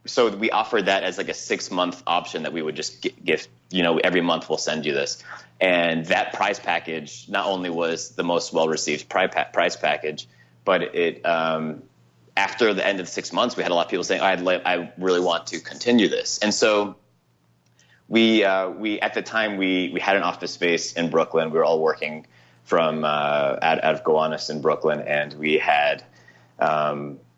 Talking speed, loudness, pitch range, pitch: 205 wpm, -22 LUFS, 75-90 Hz, 80 Hz